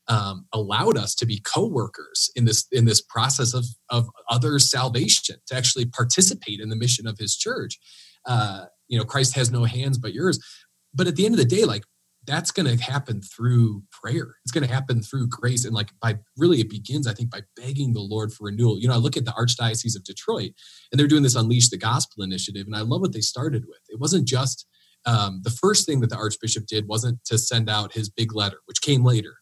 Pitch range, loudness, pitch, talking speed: 110-130 Hz, -22 LUFS, 120 Hz, 230 wpm